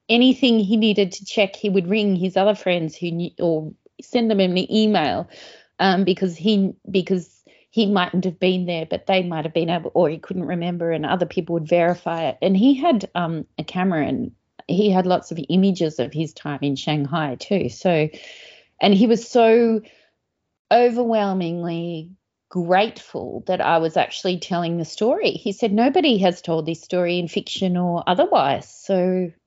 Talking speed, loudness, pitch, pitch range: 175 wpm, -20 LUFS, 185 Hz, 170-205 Hz